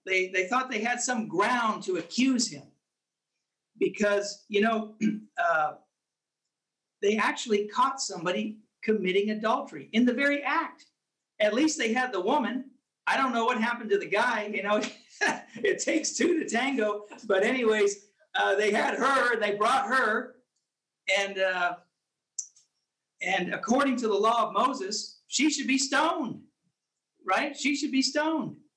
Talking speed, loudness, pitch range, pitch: 150 wpm, -27 LUFS, 205-265 Hz, 225 Hz